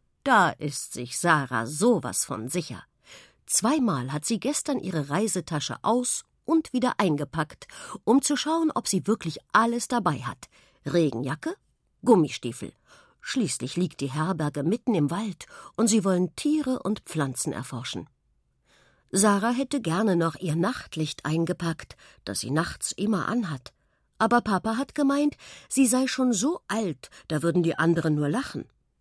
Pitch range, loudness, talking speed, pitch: 150-240 Hz, -26 LUFS, 145 wpm, 180 Hz